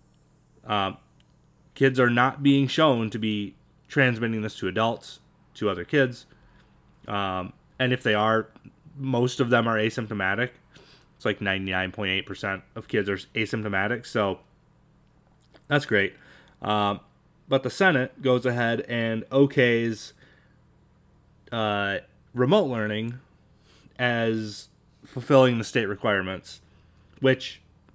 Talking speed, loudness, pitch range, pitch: 115 wpm, -25 LUFS, 105-135 Hz, 115 Hz